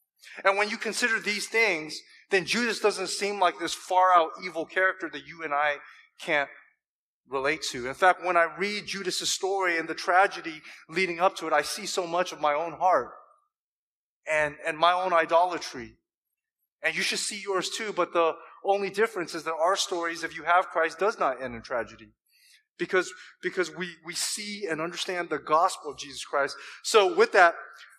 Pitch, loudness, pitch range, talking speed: 175 Hz, -26 LUFS, 160-195 Hz, 190 wpm